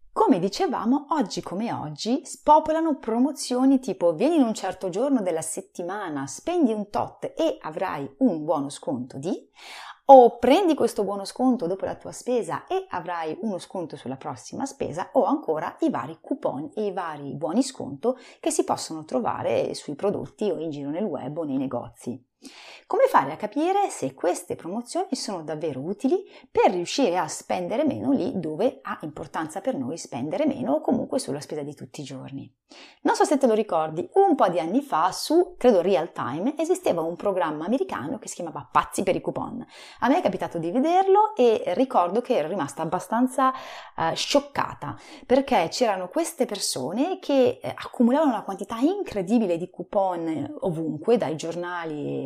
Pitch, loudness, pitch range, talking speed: 250 Hz, -25 LUFS, 180-290 Hz, 170 wpm